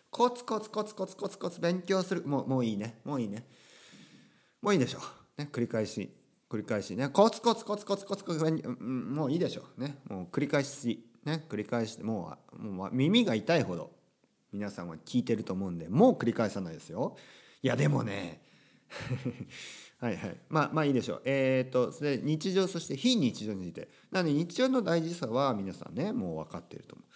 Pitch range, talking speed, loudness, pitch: 115-190 Hz, 385 characters per minute, -32 LUFS, 145 Hz